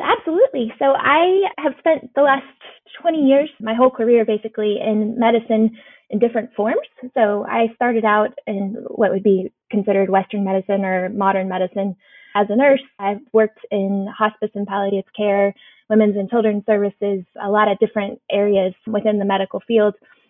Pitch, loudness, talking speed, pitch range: 215 Hz, -18 LUFS, 165 wpm, 200-240 Hz